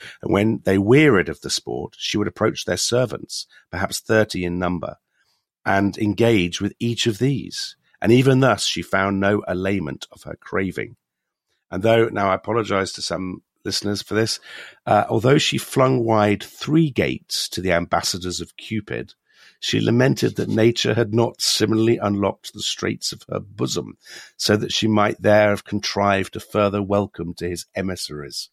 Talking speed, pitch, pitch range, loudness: 170 wpm, 105 Hz, 95-115 Hz, -20 LUFS